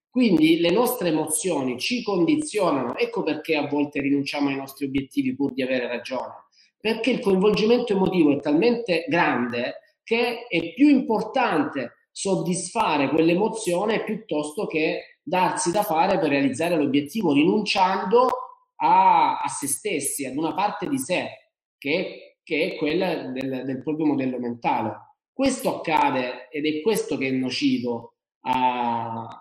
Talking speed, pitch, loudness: 135 wpm, 170 Hz, -23 LUFS